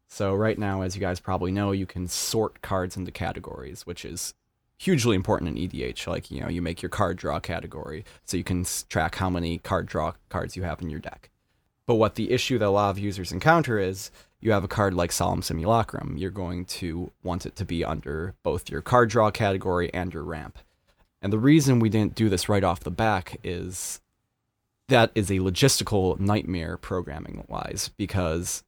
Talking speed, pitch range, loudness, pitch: 200 wpm, 90-110 Hz, -26 LUFS, 95 Hz